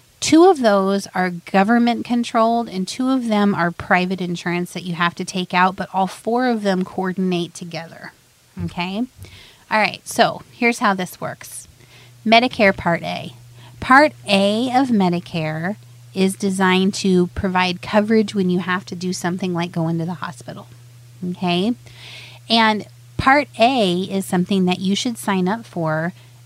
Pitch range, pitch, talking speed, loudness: 170-210 Hz, 185 Hz, 155 wpm, -18 LUFS